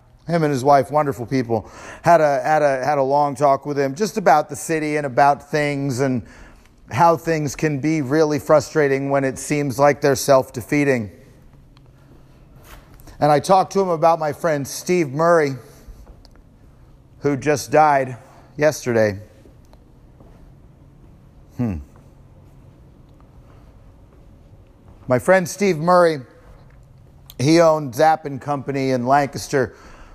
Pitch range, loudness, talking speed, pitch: 130-155 Hz, -18 LUFS, 125 wpm, 140 Hz